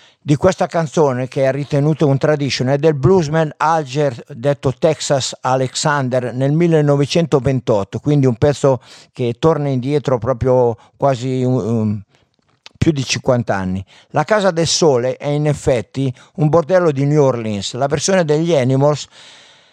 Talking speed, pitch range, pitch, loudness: 140 wpm, 130-155 Hz, 140 Hz, -16 LUFS